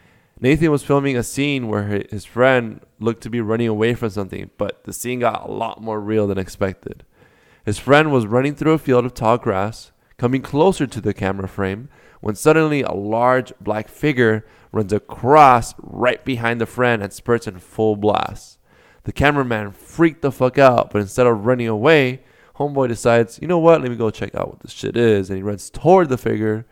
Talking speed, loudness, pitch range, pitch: 200 wpm, -18 LUFS, 105-130 Hz, 115 Hz